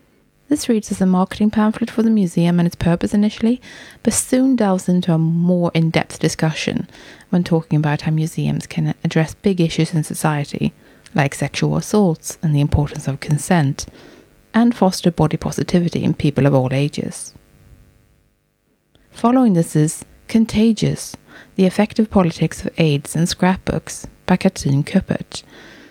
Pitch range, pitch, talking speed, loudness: 155-205 Hz, 175 Hz, 145 wpm, -18 LUFS